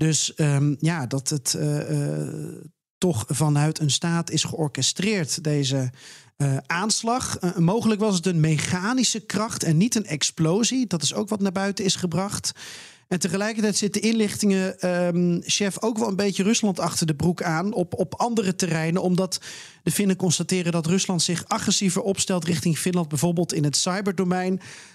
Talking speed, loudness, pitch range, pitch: 165 wpm, -23 LUFS, 155-200 Hz, 175 Hz